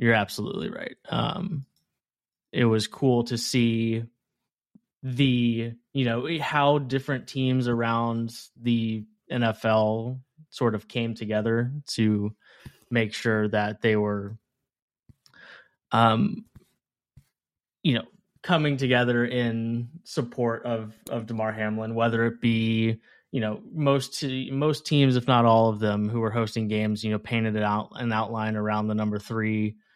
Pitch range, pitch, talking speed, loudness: 110-125 Hz, 115 Hz, 135 wpm, -26 LUFS